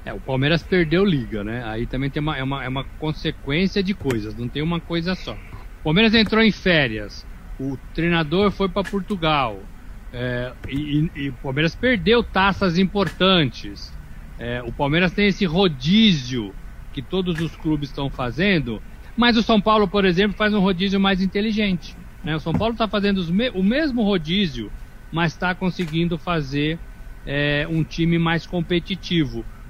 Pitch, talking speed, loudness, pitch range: 165 Hz, 165 wpm, -21 LUFS, 130-195 Hz